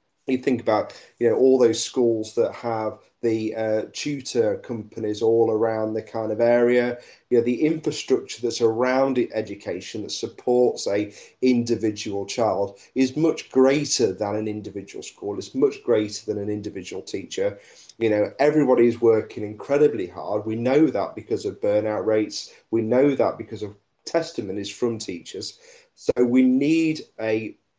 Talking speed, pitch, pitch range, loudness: 155 wpm, 115 Hz, 110-130 Hz, -23 LUFS